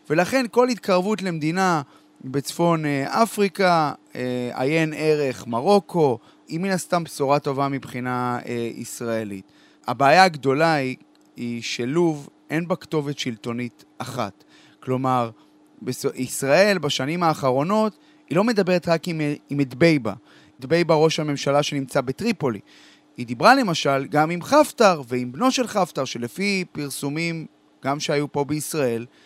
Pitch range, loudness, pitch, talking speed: 130-175 Hz, -22 LUFS, 150 Hz, 125 wpm